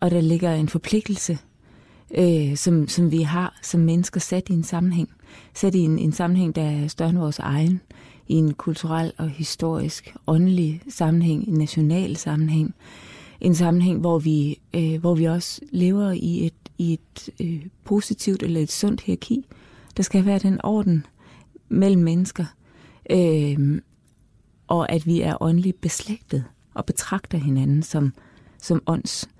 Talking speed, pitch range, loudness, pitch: 155 wpm, 160-180 Hz, -22 LUFS, 170 Hz